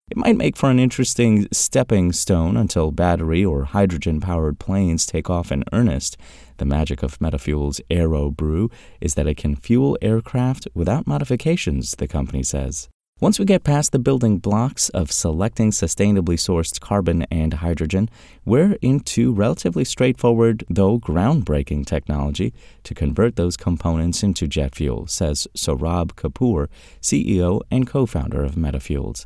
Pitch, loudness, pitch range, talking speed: 90 Hz, -20 LUFS, 75-115 Hz, 145 wpm